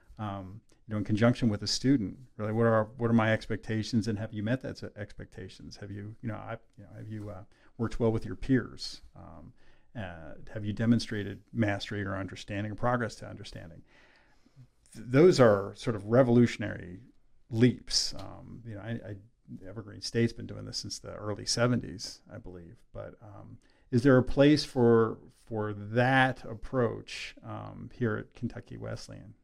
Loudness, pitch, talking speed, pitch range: -29 LUFS, 110 Hz, 175 wpm, 105-120 Hz